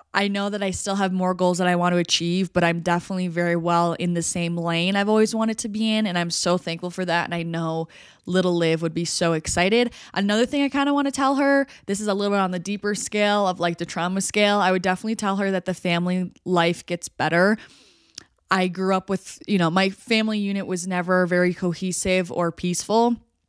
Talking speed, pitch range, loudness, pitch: 235 wpm, 175-205 Hz, -22 LUFS, 185 Hz